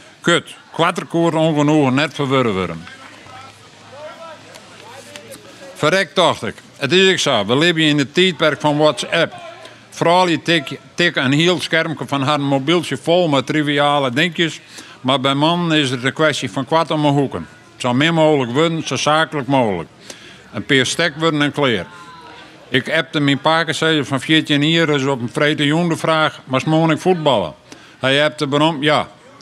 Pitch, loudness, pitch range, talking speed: 150 Hz, -16 LUFS, 140-165 Hz, 165 wpm